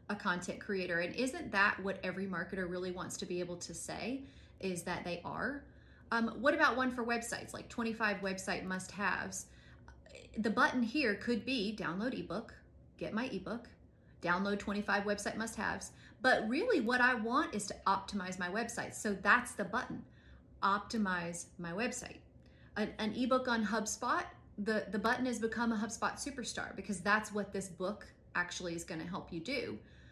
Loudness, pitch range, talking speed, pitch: -36 LUFS, 185-235 Hz, 170 wpm, 205 Hz